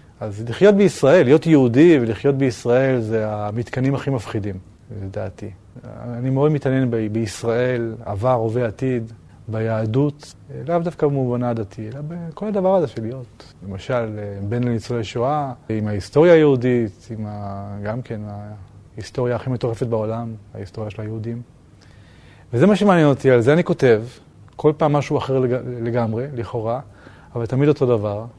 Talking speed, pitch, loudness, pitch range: 140 wpm, 120 Hz, -19 LUFS, 110-135 Hz